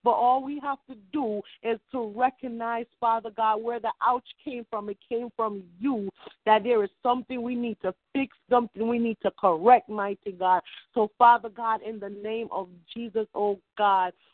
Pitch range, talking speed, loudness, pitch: 205-245 Hz, 190 wpm, -27 LUFS, 225 Hz